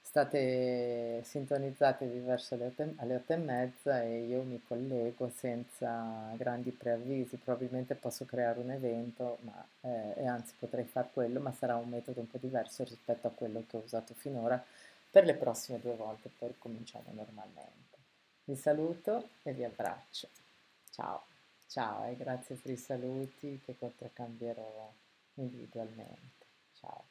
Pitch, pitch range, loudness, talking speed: 125 Hz, 120-130 Hz, -37 LUFS, 140 wpm